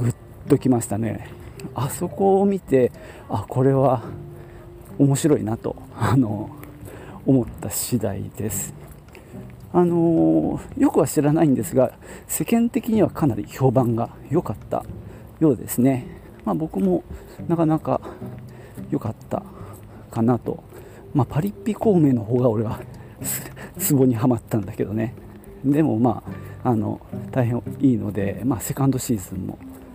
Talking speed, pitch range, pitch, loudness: 250 characters per minute, 110-145 Hz, 125 Hz, -22 LUFS